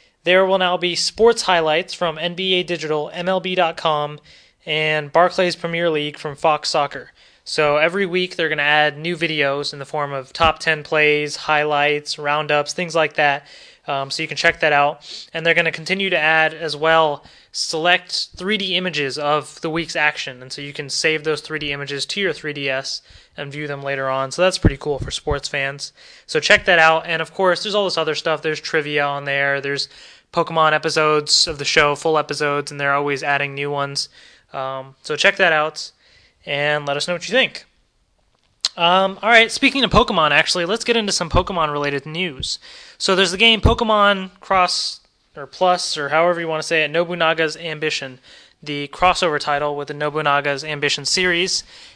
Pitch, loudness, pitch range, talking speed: 155 Hz, -18 LUFS, 145-175 Hz, 190 wpm